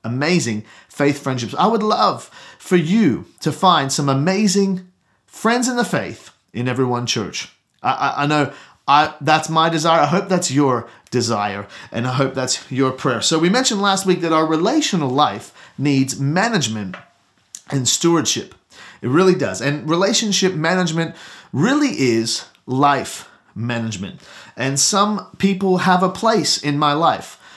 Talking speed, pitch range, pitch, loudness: 155 wpm, 130-185 Hz, 150 Hz, -18 LUFS